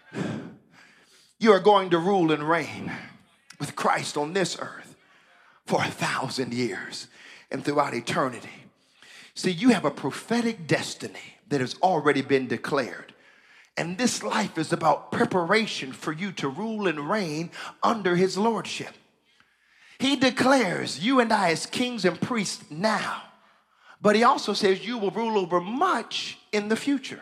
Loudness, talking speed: -25 LUFS, 150 wpm